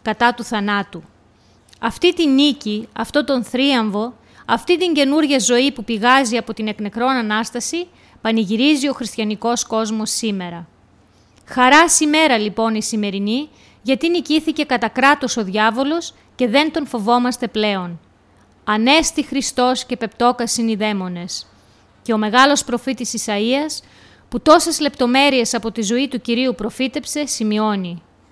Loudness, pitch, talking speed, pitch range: -17 LUFS, 240 Hz, 130 wpm, 215-275 Hz